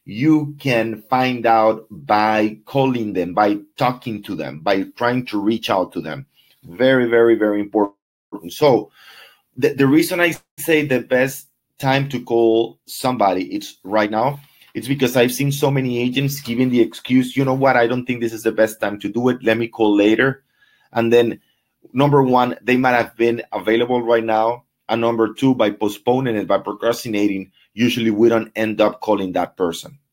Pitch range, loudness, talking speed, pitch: 110-130 Hz, -18 LUFS, 185 wpm, 120 Hz